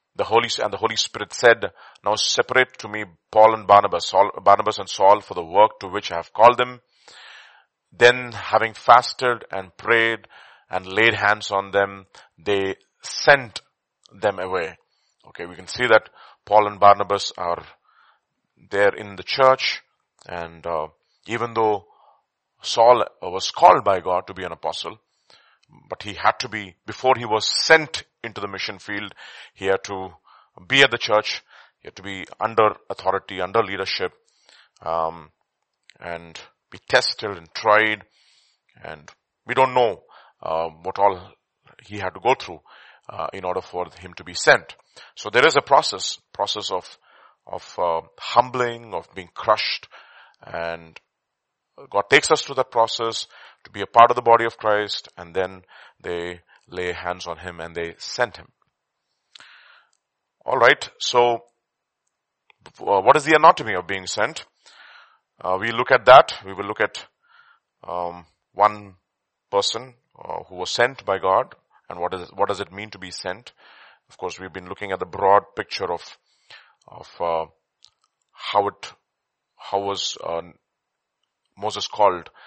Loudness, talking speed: -20 LUFS, 160 wpm